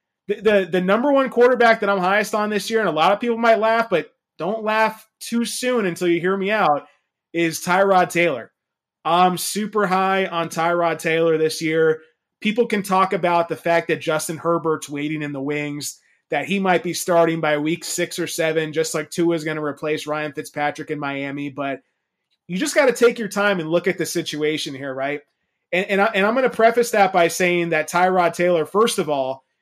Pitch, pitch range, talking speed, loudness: 175 Hz, 155-205 Hz, 215 wpm, -20 LUFS